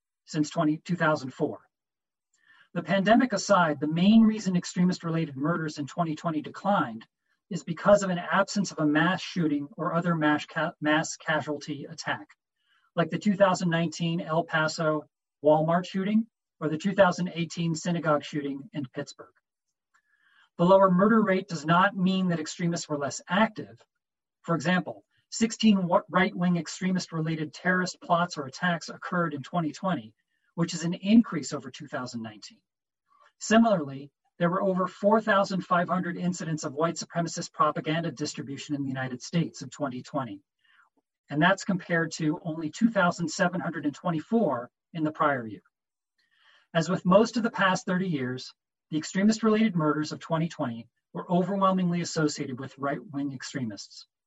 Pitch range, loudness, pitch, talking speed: 150-185 Hz, -27 LUFS, 170 Hz, 140 wpm